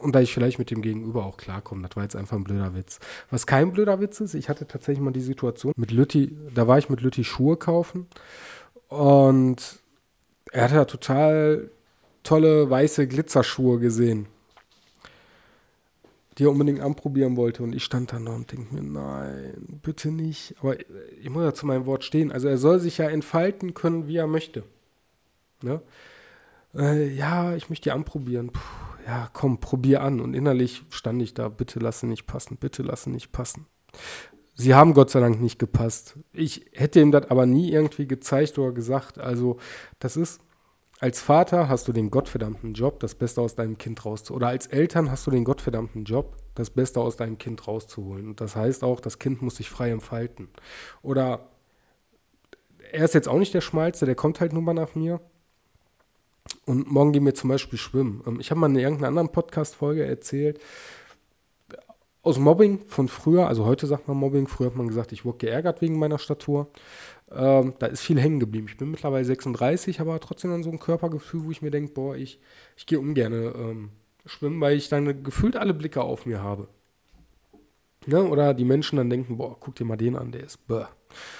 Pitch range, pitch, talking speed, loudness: 120-155 Hz, 135 Hz, 190 wpm, -24 LUFS